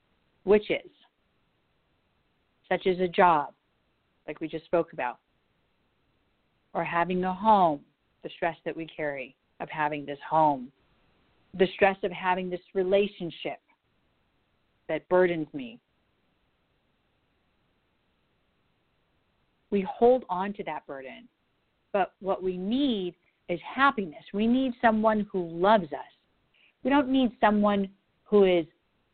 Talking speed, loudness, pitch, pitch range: 115 wpm, -27 LUFS, 185 Hz, 165-210 Hz